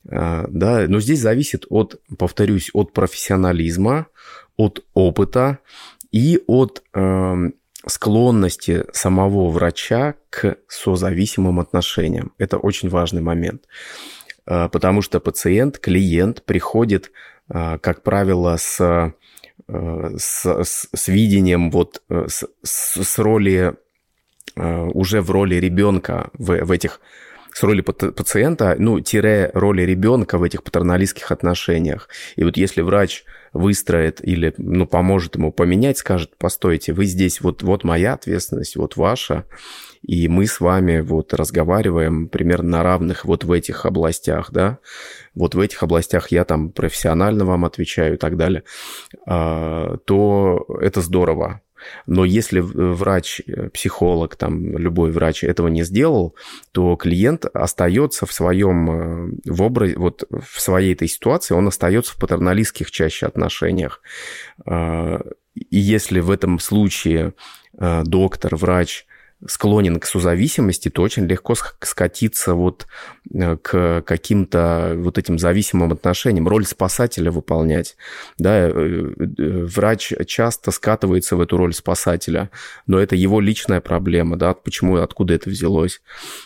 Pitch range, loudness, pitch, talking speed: 85-100 Hz, -18 LUFS, 90 Hz, 120 wpm